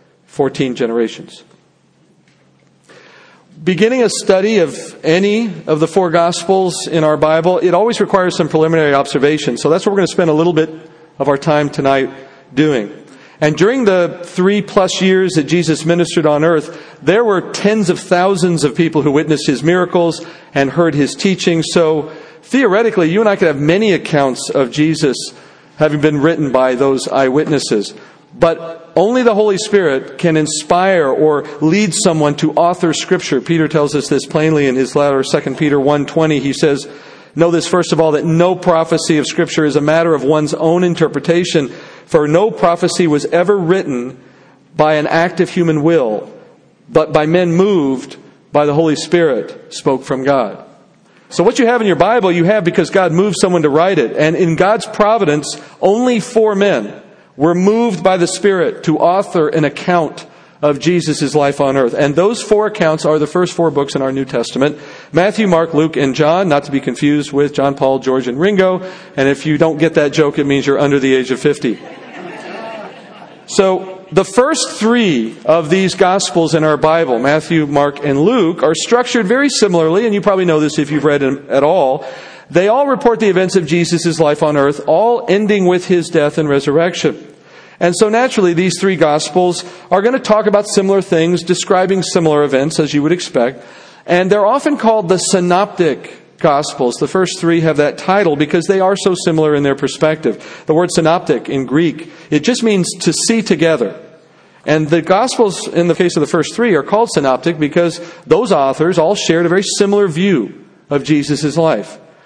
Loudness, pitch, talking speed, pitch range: -13 LUFS, 165 Hz, 185 wpm, 150-185 Hz